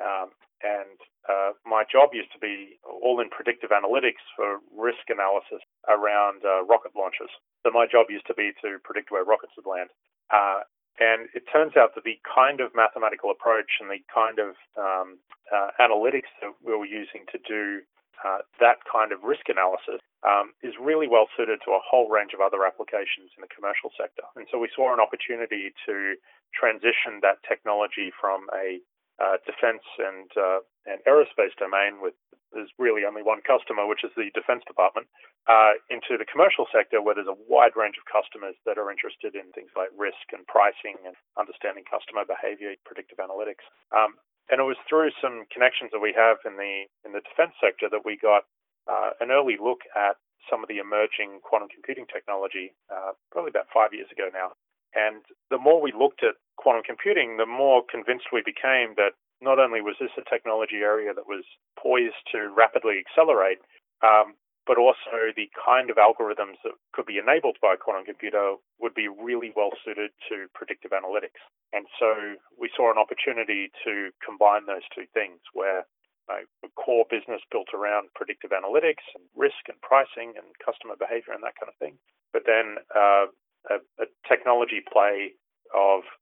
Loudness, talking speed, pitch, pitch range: -24 LUFS, 185 wpm, 115 Hz, 105-160 Hz